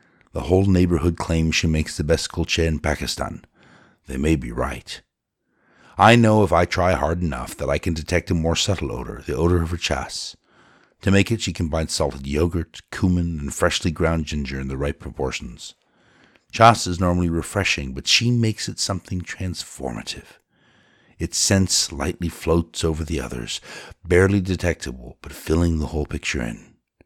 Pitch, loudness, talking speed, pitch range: 85 Hz, -21 LUFS, 170 wpm, 75-90 Hz